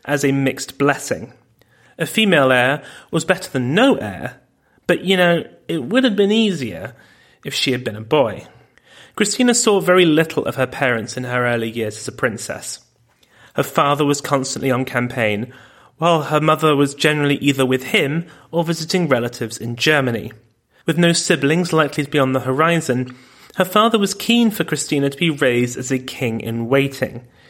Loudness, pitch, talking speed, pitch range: -18 LUFS, 140 Hz, 180 wpm, 125-170 Hz